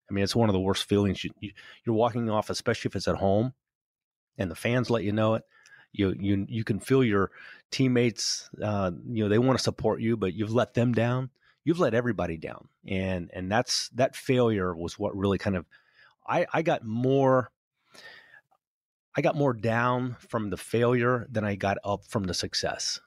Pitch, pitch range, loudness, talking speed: 110 Hz, 100-125 Hz, -27 LUFS, 200 wpm